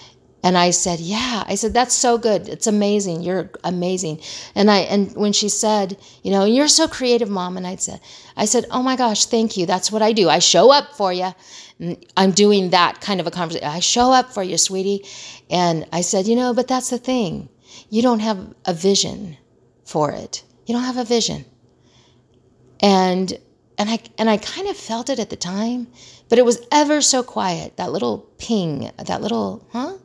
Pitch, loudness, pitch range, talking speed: 205 Hz, -18 LUFS, 180-235 Hz, 205 wpm